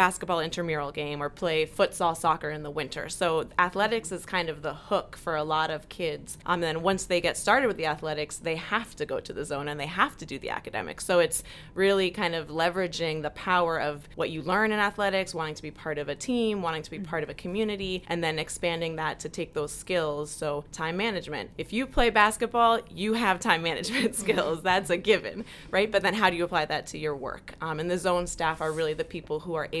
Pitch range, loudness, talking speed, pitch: 155-195 Hz, -28 LUFS, 240 wpm, 170 Hz